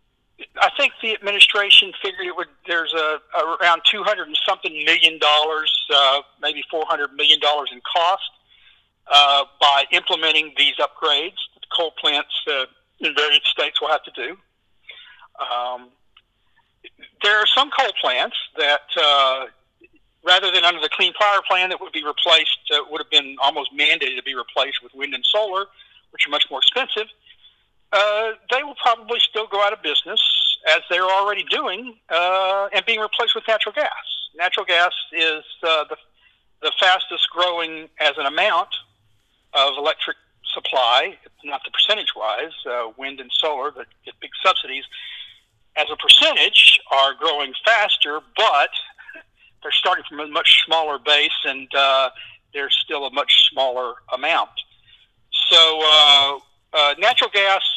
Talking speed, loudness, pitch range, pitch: 155 wpm, -17 LUFS, 145-205 Hz, 165 Hz